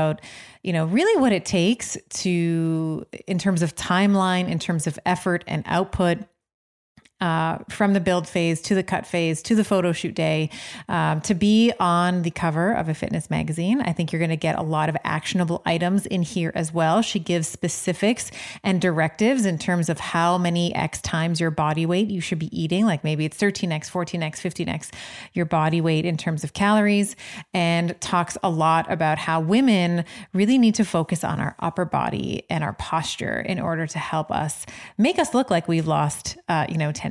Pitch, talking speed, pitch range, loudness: 175 Hz, 195 wpm, 165-190 Hz, -23 LUFS